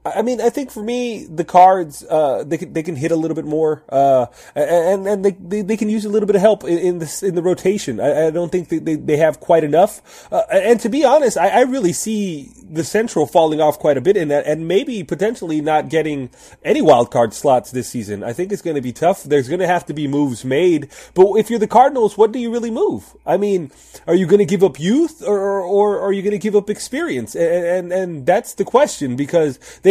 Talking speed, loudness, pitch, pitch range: 255 wpm, -17 LUFS, 180 Hz, 155-210 Hz